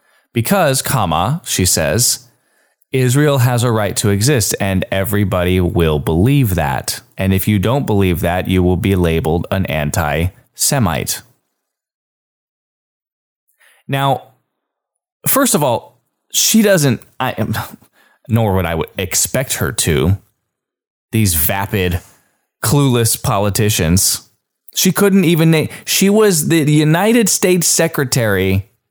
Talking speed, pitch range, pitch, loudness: 115 wpm, 90-140 Hz, 110 Hz, -14 LUFS